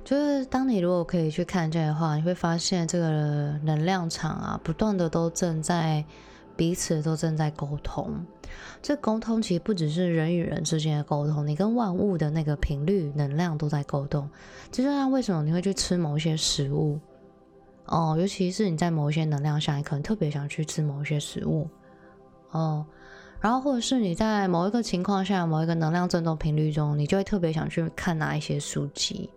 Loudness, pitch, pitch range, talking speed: -27 LUFS, 165 Hz, 150-185 Hz, 295 characters per minute